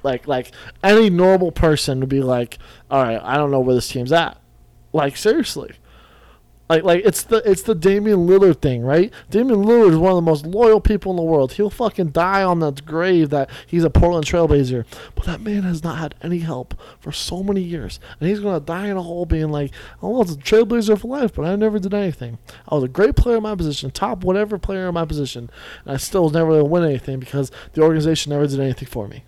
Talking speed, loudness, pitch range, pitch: 240 wpm, -18 LUFS, 135-195 Hz, 165 Hz